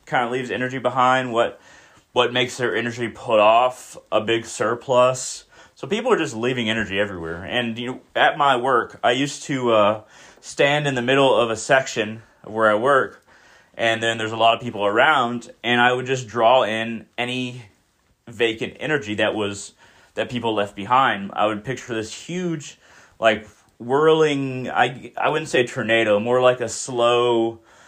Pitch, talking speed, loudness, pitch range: 120 Hz, 175 wpm, -20 LUFS, 110-125 Hz